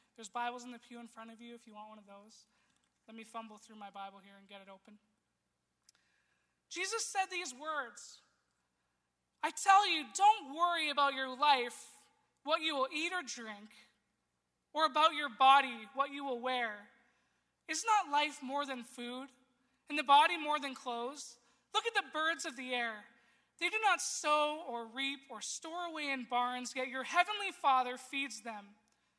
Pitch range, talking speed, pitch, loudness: 235-310 Hz, 180 wpm, 270 Hz, -34 LUFS